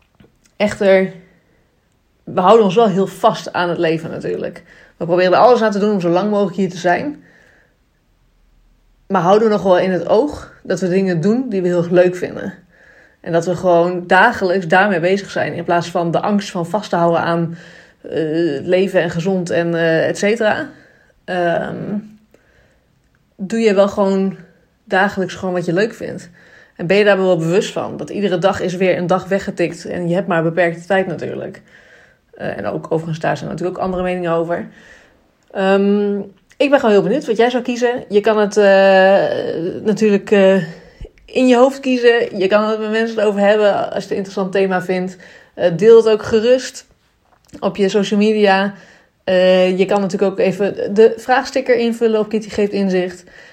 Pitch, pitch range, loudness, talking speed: 195 Hz, 180-210 Hz, -15 LUFS, 190 wpm